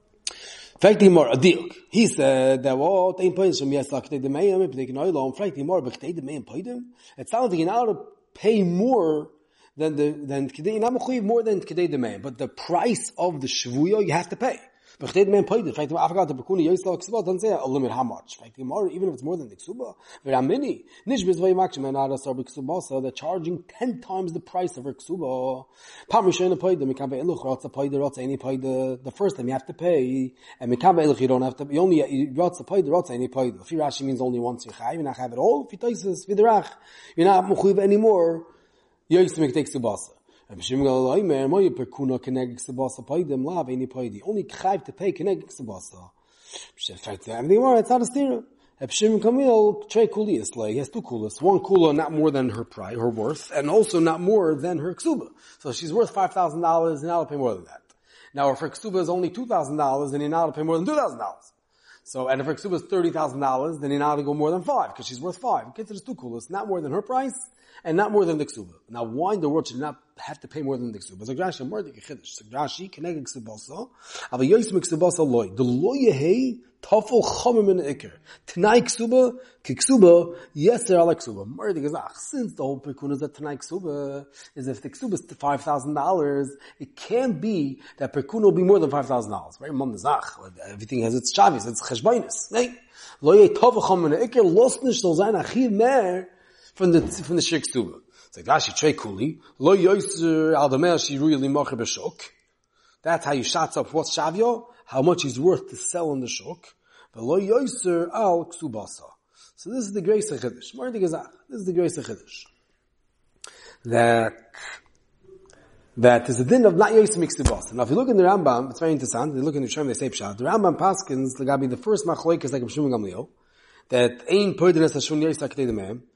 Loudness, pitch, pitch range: -23 LUFS, 165 Hz, 135-205 Hz